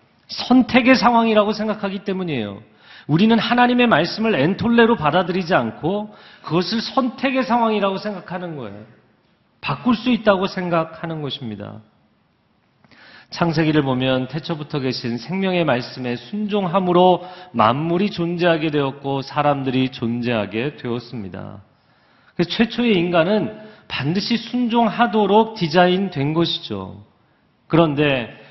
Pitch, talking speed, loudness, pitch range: 175 Hz, 295 characters per minute, -19 LUFS, 135-210 Hz